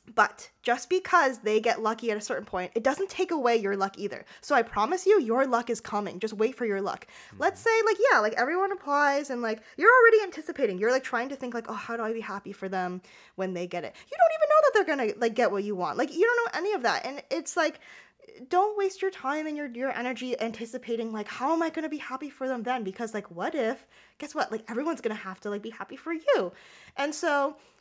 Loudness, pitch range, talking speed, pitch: -27 LUFS, 220-330 Hz, 265 wpm, 255 Hz